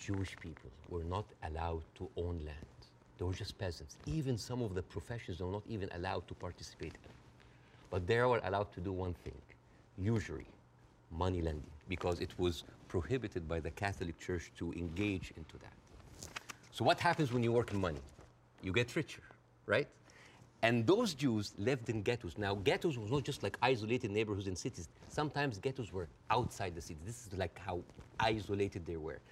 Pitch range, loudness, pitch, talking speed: 85-115 Hz, -38 LUFS, 95 Hz, 180 wpm